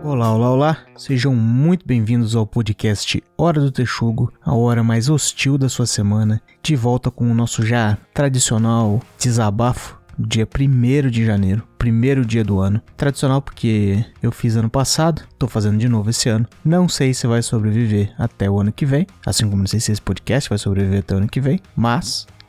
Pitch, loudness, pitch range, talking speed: 115 Hz, -18 LUFS, 110-130 Hz, 190 wpm